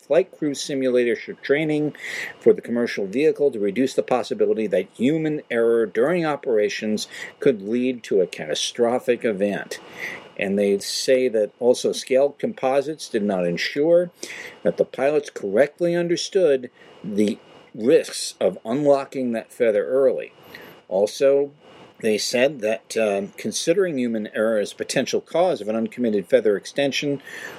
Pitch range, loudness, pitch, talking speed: 115-175 Hz, -22 LUFS, 140 Hz, 135 wpm